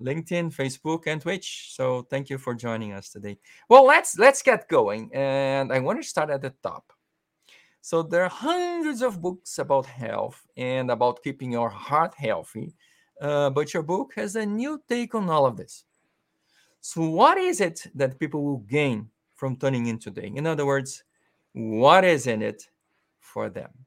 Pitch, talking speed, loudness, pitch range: 140 Hz, 180 wpm, -24 LUFS, 130-180 Hz